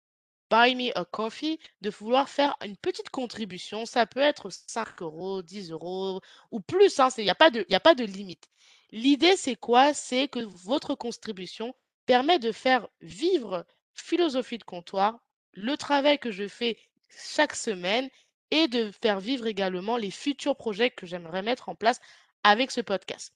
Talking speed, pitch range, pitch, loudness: 165 wpm, 200-275 Hz, 235 Hz, -26 LUFS